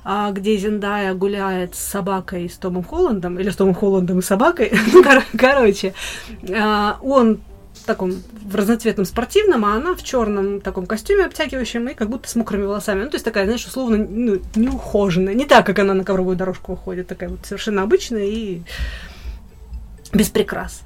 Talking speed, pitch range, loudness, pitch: 175 wpm, 190-225 Hz, -18 LUFS, 205 Hz